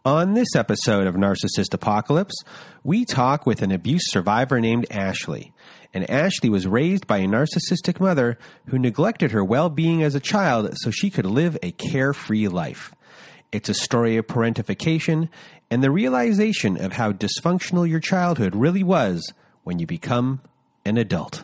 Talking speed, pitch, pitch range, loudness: 155 wpm, 145 Hz, 115-175 Hz, -21 LUFS